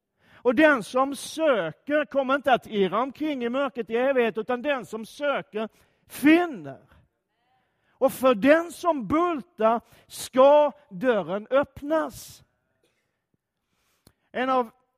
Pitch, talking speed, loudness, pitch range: 265 Hz, 110 wpm, -24 LUFS, 235-290 Hz